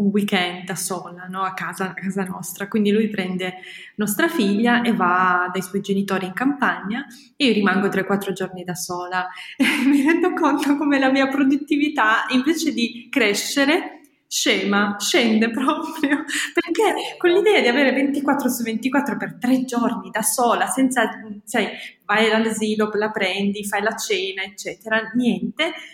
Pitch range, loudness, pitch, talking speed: 200-280 Hz, -20 LUFS, 225 Hz, 155 wpm